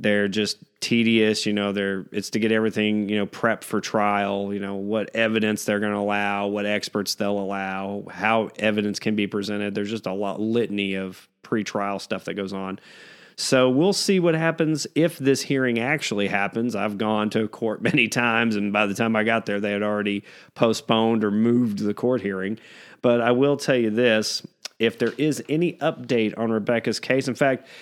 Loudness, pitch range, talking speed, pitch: -23 LUFS, 100-120 Hz, 195 wpm, 110 Hz